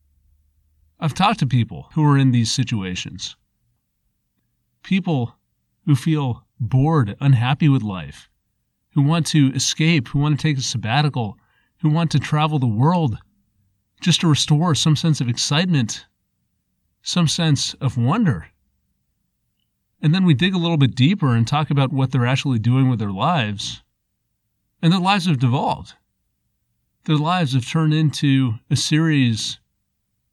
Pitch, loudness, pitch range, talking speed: 135 Hz, -19 LUFS, 115-155 Hz, 145 wpm